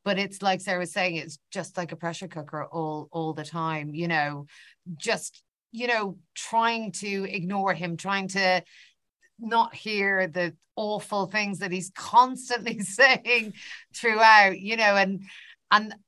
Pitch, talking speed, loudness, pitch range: 195 Hz, 155 wpm, -25 LUFS, 175-215 Hz